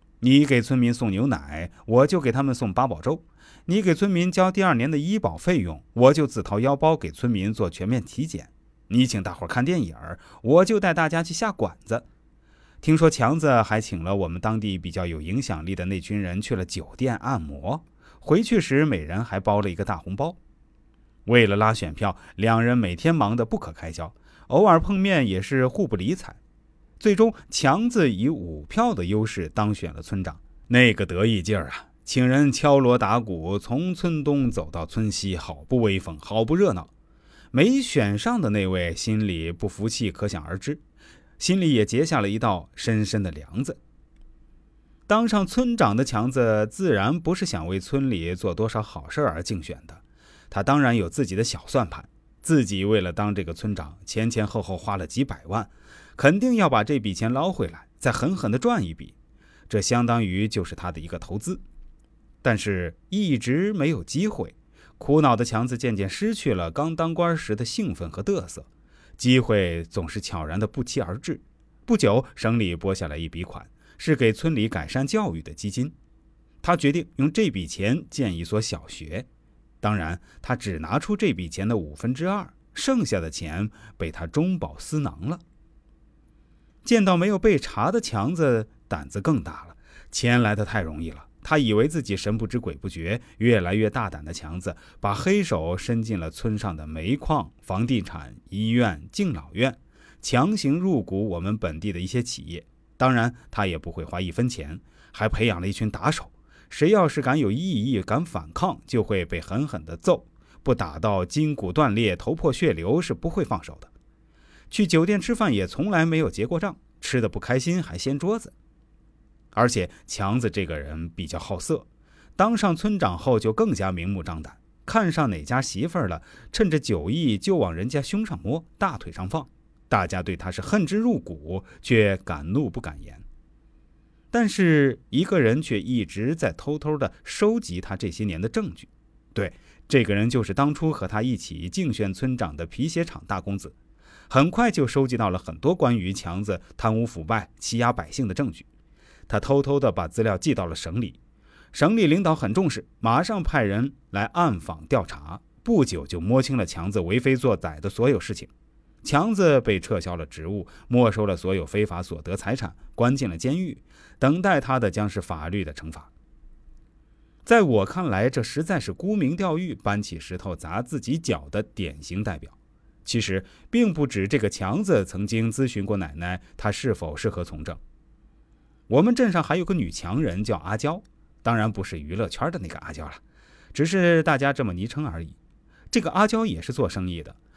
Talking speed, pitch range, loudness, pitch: 265 characters per minute, 95-145 Hz, -24 LUFS, 110 Hz